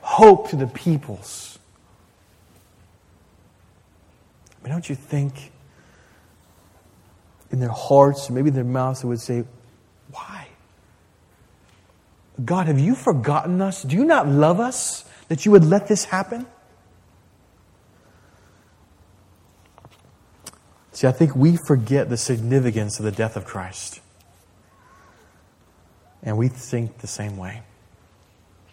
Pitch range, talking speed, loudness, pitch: 90-140 Hz, 115 wpm, -20 LUFS, 110 Hz